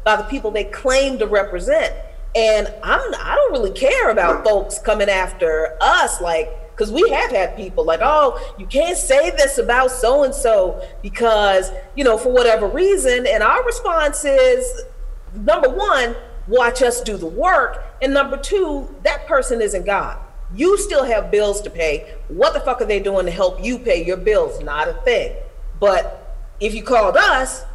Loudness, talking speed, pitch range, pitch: -17 LUFS, 185 wpm, 205-320 Hz, 250 Hz